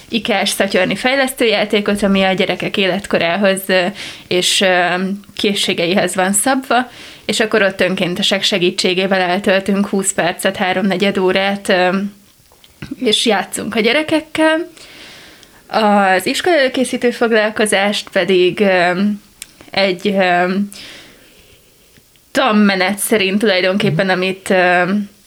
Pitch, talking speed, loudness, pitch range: 200 Hz, 80 wpm, -14 LUFS, 185-215 Hz